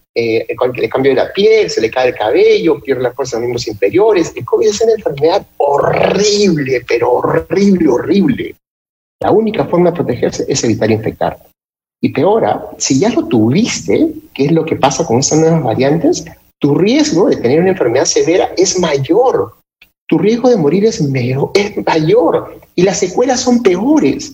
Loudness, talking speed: -12 LUFS, 175 wpm